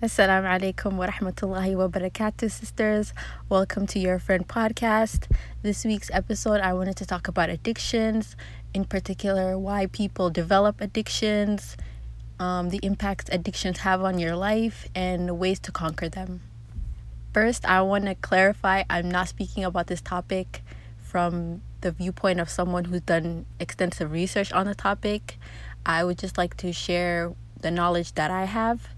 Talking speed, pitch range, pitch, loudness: 155 wpm, 175-200 Hz, 190 Hz, -26 LUFS